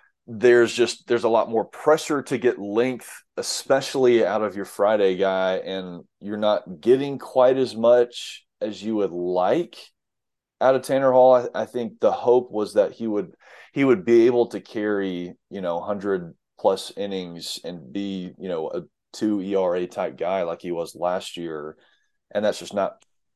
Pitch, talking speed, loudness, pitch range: 105 Hz, 175 wpm, -22 LUFS, 95-125 Hz